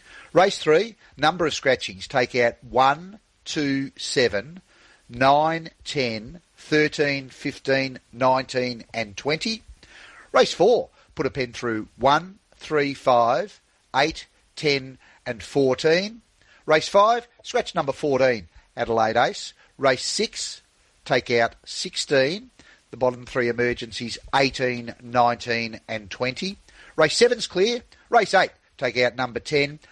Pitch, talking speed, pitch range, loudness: 135 Hz, 120 wpm, 120-165 Hz, -23 LUFS